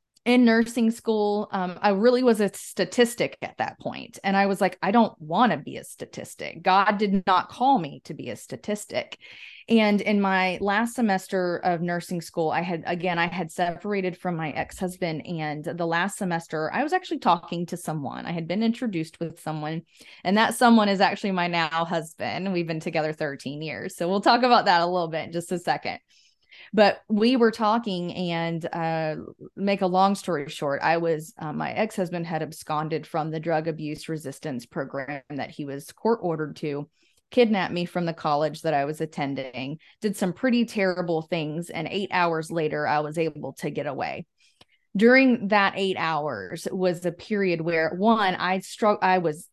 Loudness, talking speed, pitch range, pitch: -25 LUFS, 190 wpm, 160-200 Hz, 175 Hz